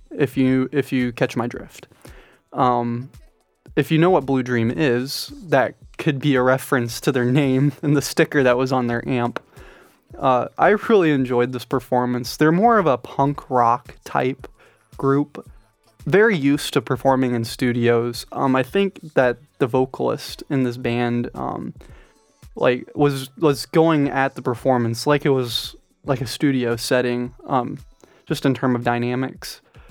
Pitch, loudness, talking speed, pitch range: 130 Hz, -20 LUFS, 165 wpm, 120-145 Hz